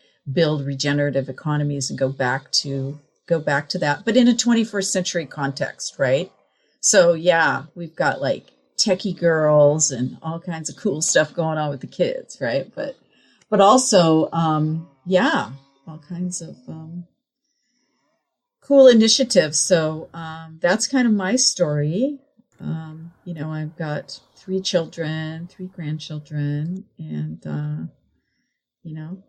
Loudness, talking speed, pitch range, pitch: -20 LUFS, 140 wpm, 150-190 Hz, 165 Hz